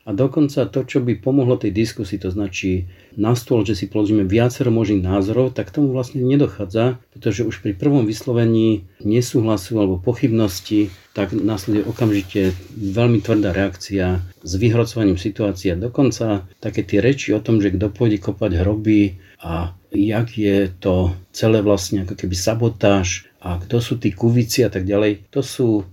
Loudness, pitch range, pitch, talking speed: -19 LUFS, 100-120 Hz, 105 Hz, 160 wpm